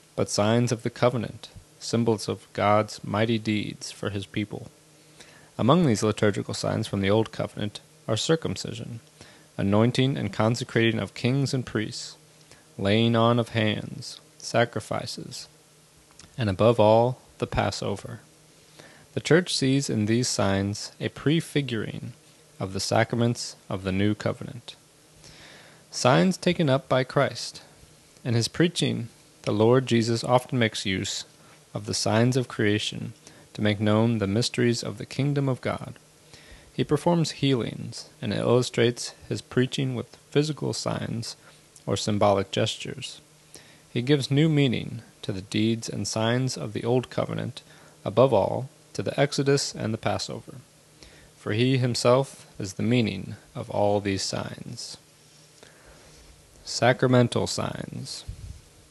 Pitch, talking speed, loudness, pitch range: 120 Hz, 130 wpm, -25 LUFS, 110-145 Hz